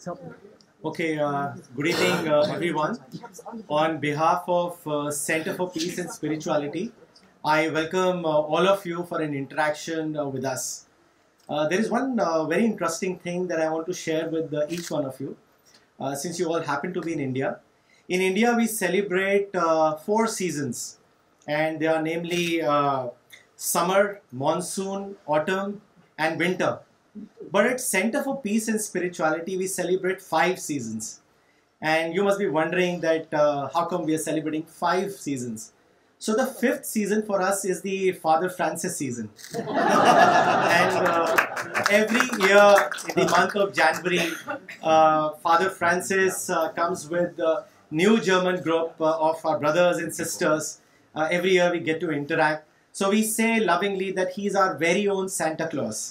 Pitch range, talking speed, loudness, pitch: 155-190 Hz, 125 wpm, -24 LUFS, 170 Hz